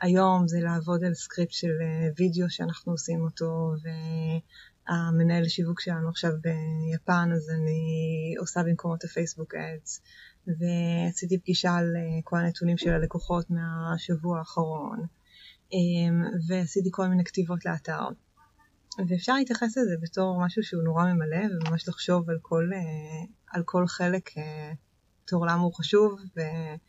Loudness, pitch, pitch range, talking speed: -28 LUFS, 170 Hz, 165-180 Hz, 125 wpm